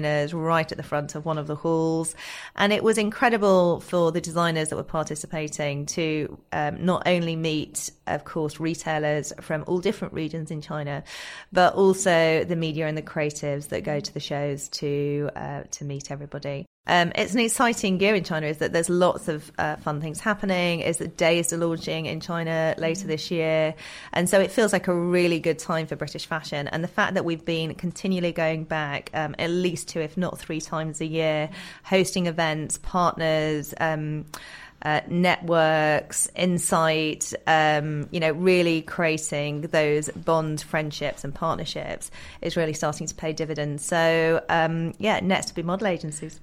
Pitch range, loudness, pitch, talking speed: 155-175 Hz, -25 LUFS, 160 Hz, 180 wpm